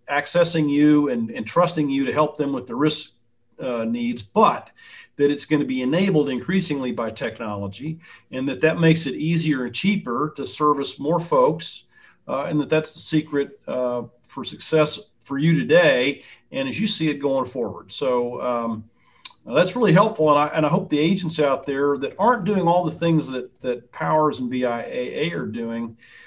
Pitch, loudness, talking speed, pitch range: 150 Hz, -22 LUFS, 185 wpm, 125-160 Hz